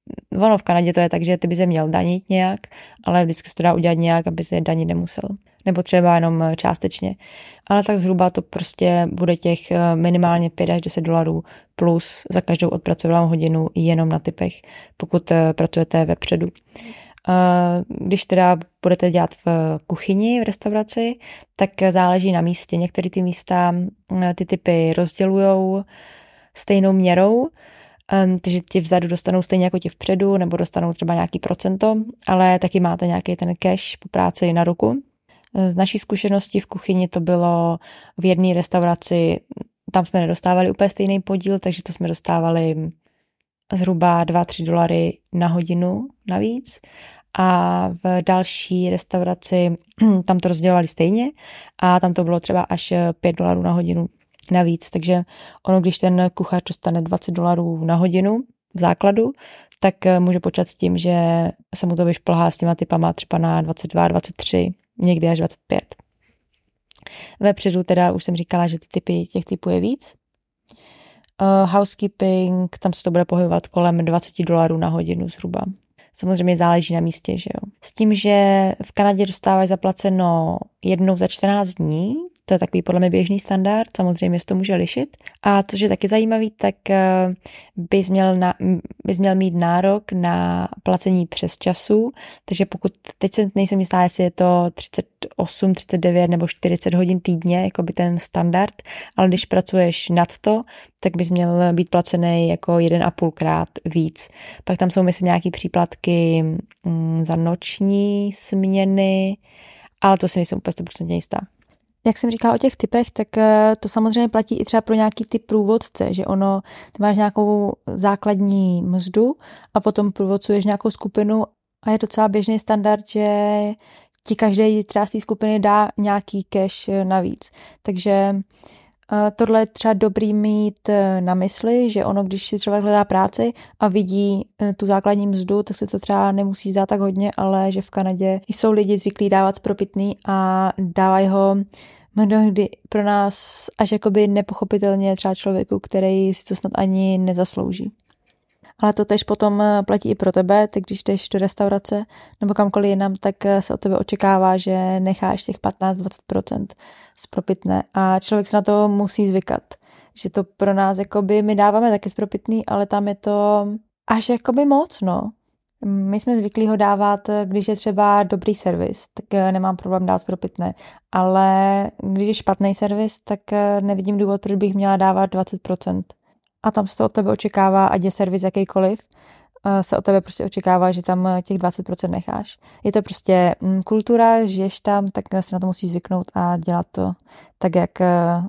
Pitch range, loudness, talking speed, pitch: 175-205 Hz, -19 LUFS, 160 wpm, 190 Hz